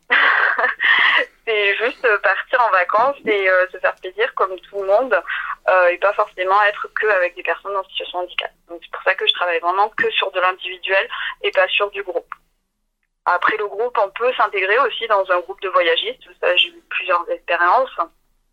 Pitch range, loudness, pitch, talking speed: 185-300 Hz, -18 LUFS, 200 Hz, 190 wpm